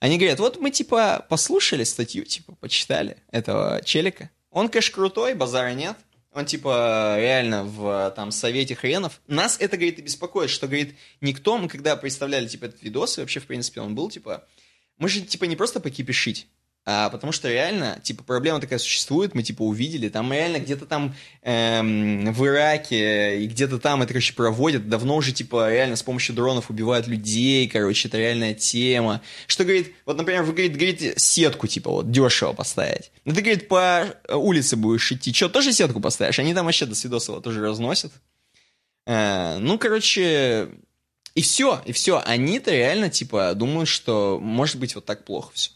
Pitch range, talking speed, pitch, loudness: 115-160 Hz, 175 wpm, 130 Hz, -22 LUFS